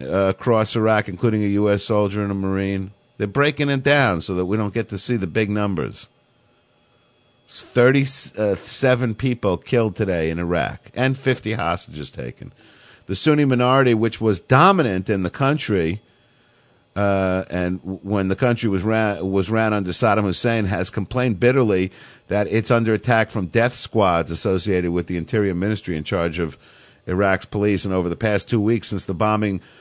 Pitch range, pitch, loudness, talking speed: 95-120 Hz, 105 Hz, -20 LUFS, 170 wpm